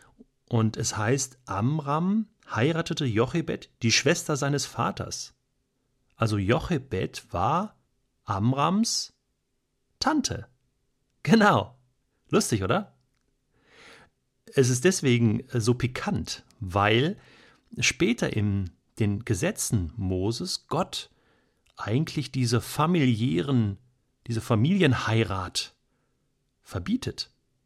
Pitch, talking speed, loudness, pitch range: 125 Hz, 80 wpm, -26 LUFS, 115-150 Hz